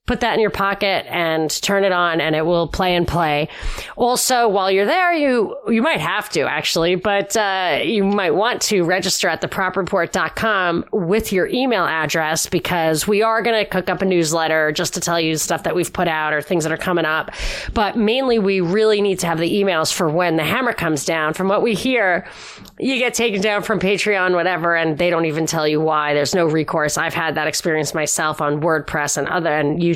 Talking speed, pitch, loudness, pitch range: 220 wpm, 180 Hz, -18 LUFS, 160-205 Hz